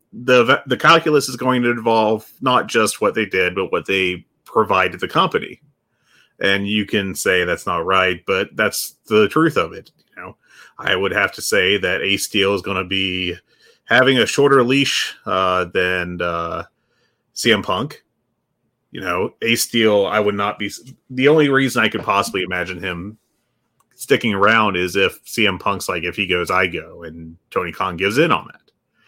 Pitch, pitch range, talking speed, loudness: 105 Hz, 90-120 Hz, 185 wpm, -17 LUFS